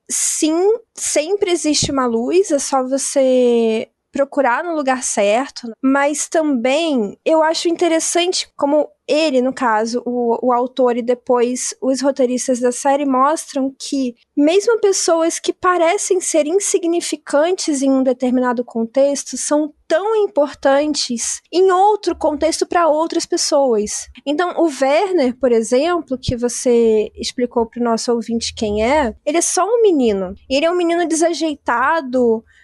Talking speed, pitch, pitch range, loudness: 140 wpm, 280 Hz, 250-330 Hz, -17 LUFS